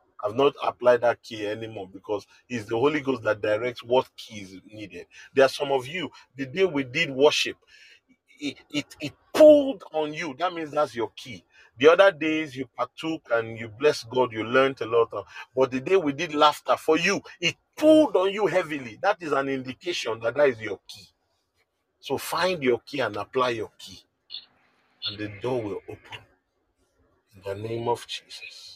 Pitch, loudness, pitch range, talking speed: 135 Hz, -24 LUFS, 115-165 Hz, 190 wpm